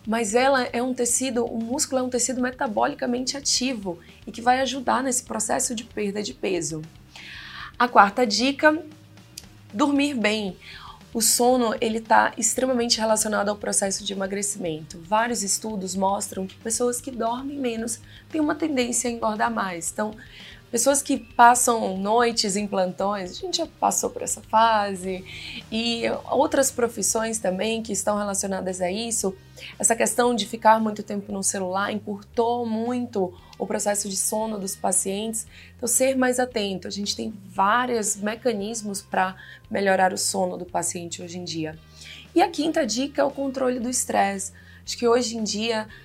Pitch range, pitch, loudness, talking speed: 195-245 Hz, 225 Hz, -23 LUFS, 160 wpm